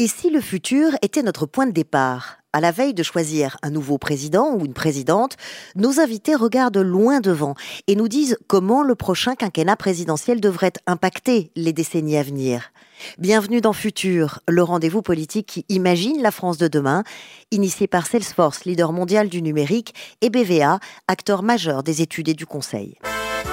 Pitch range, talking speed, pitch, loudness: 160-220 Hz, 170 wpm, 185 Hz, -20 LUFS